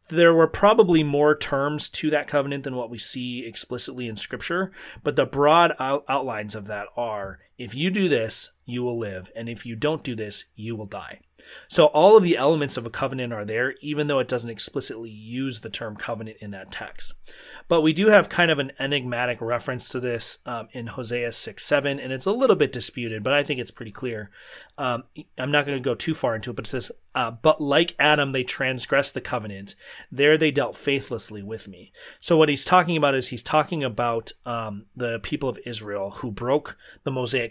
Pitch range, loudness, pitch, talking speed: 115-150 Hz, -23 LUFS, 130 Hz, 215 wpm